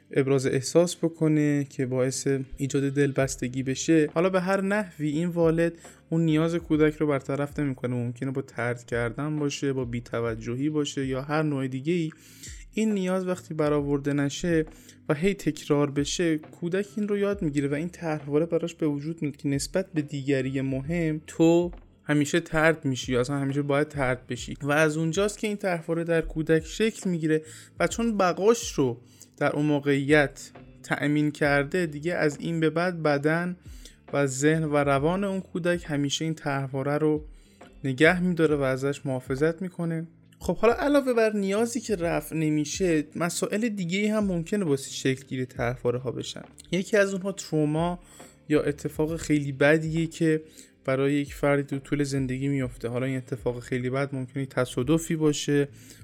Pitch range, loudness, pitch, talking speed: 135-170 Hz, -26 LUFS, 150 Hz, 165 wpm